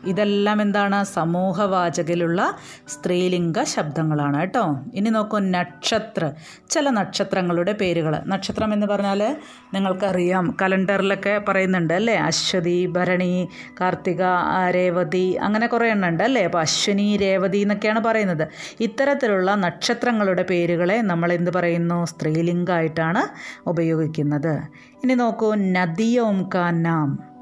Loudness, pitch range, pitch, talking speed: -21 LUFS, 175-205 Hz, 185 Hz, 95 wpm